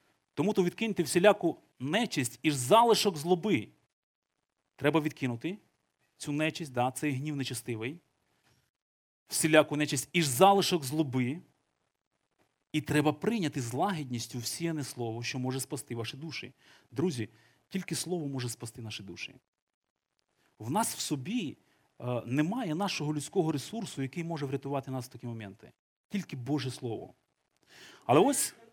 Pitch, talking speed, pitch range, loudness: 145 Hz, 125 wpm, 125-170 Hz, -31 LUFS